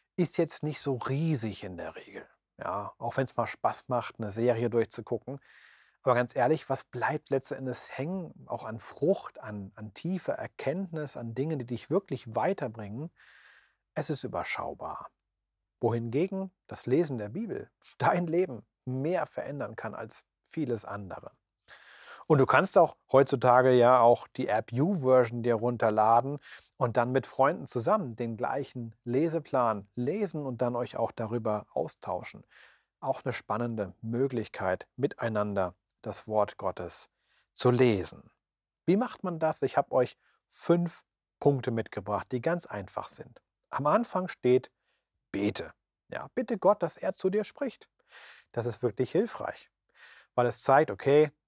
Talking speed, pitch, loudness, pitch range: 145 wpm, 125 Hz, -30 LUFS, 115-150 Hz